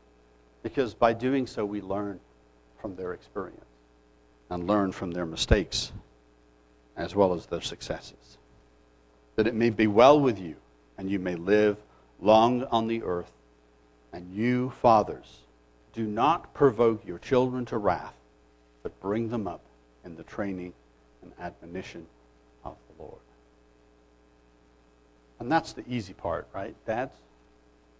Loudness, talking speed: -27 LUFS, 135 wpm